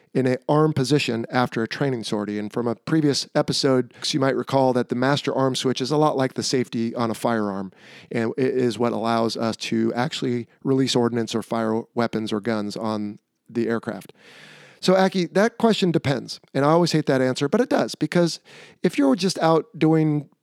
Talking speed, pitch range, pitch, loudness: 200 wpm, 115-150 Hz, 130 Hz, -22 LUFS